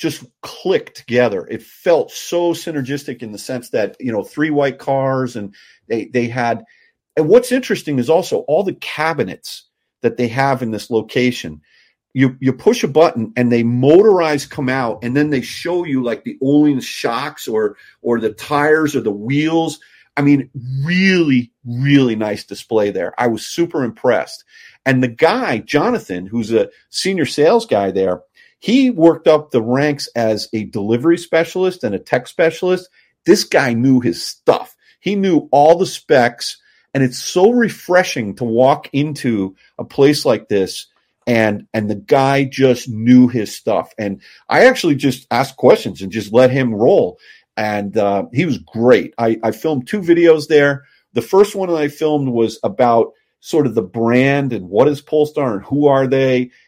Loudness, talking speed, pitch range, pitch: -16 LUFS, 175 wpm, 120-160 Hz, 135 Hz